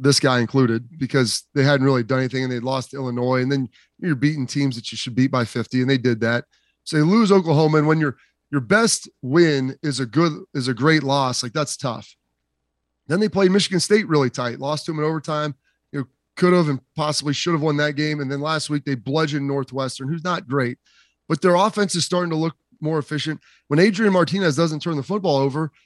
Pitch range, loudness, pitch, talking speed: 130-160 Hz, -20 LUFS, 145 Hz, 230 wpm